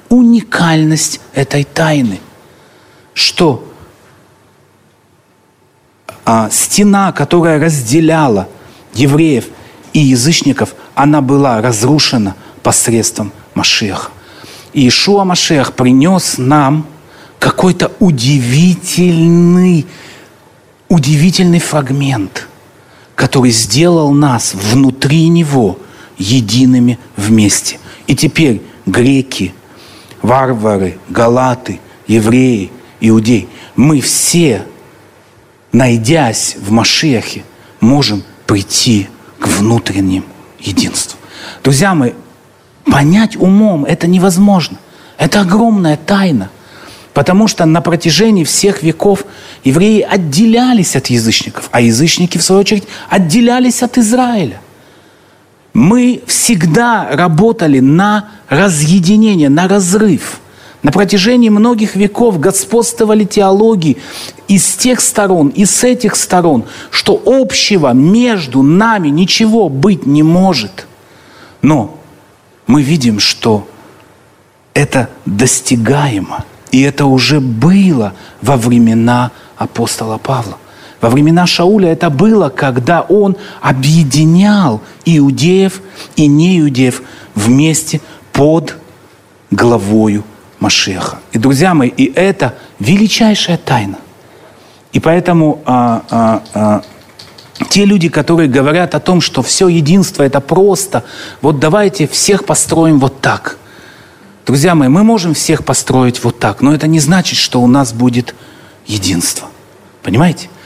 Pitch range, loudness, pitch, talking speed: 125-190 Hz, -10 LUFS, 150 Hz, 100 wpm